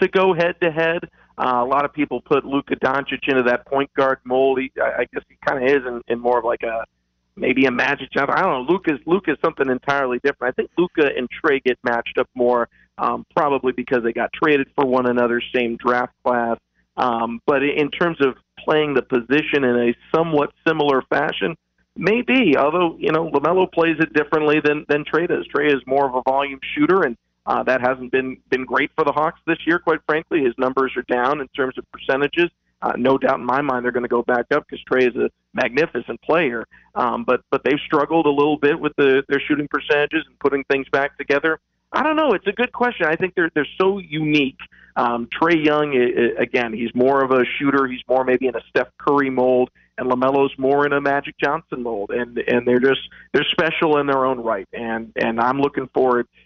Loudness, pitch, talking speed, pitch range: -20 LUFS, 140 Hz, 220 wpm, 125-155 Hz